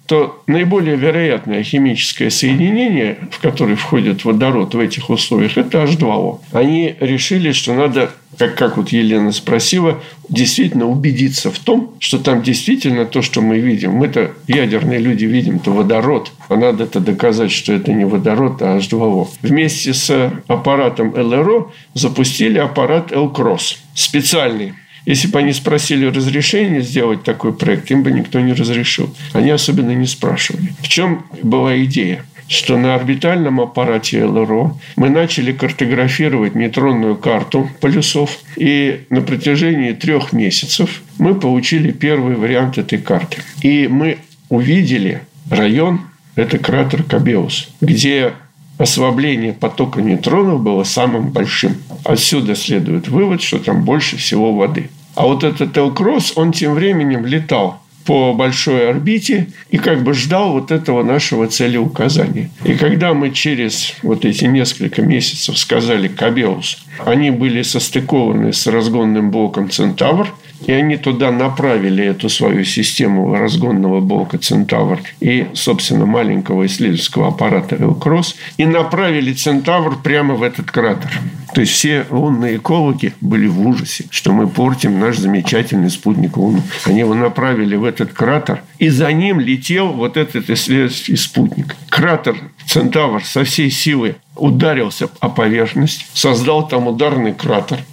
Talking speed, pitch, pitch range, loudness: 135 wpm, 145 Hz, 125-160 Hz, -14 LUFS